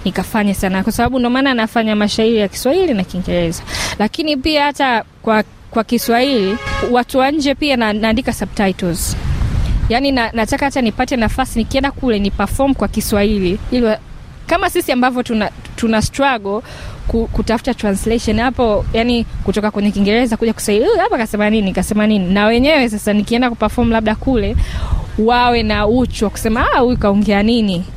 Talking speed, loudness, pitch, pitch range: 120 wpm, -15 LUFS, 225 Hz, 210-250 Hz